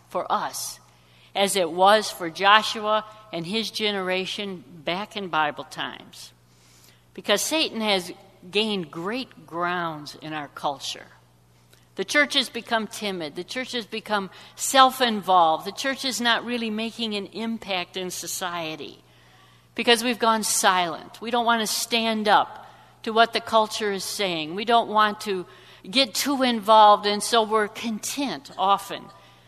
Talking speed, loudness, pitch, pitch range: 145 wpm, -23 LUFS, 210 Hz, 175-225 Hz